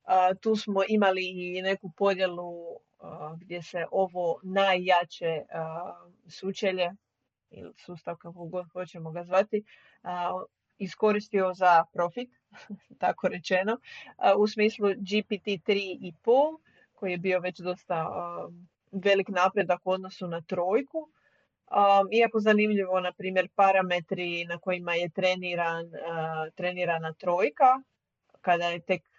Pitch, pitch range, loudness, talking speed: 185 Hz, 175-200 Hz, -28 LUFS, 125 wpm